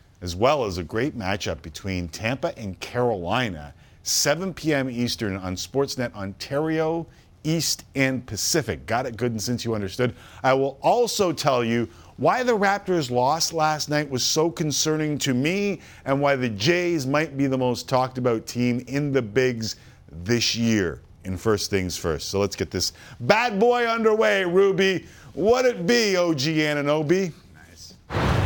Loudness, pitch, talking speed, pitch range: -23 LUFS, 130 Hz, 160 wpm, 105-160 Hz